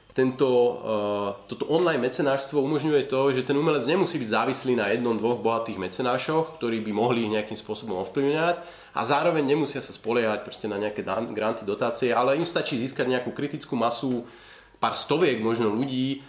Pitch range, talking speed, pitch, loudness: 115-140 Hz, 165 wpm, 125 Hz, -26 LUFS